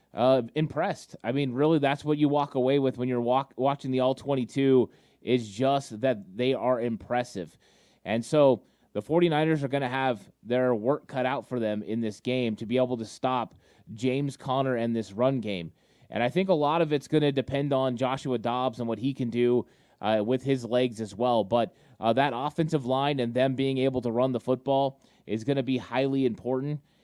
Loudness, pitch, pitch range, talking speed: -27 LUFS, 130 Hz, 120-140 Hz, 210 wpm